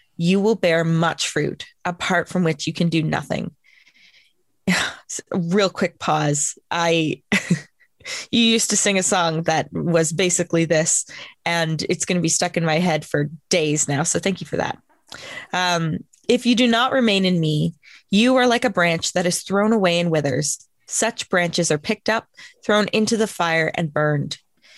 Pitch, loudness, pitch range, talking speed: 175 Hz, -20 LUFS, 160-200 Hz, 175 wpm